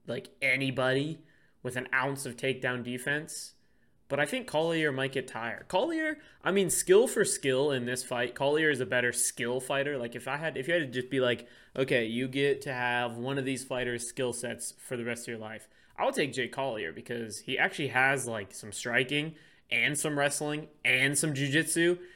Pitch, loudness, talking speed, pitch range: 130 Hz, -30 LUFS, 205 wpm, 125-145 Hz